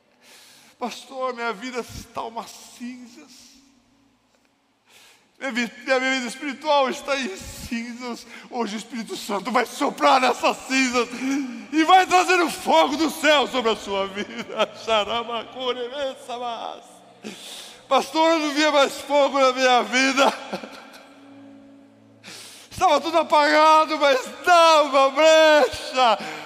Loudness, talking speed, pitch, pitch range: -20 LUFS, 110 wpm, 265 Hz, 240-285 Hz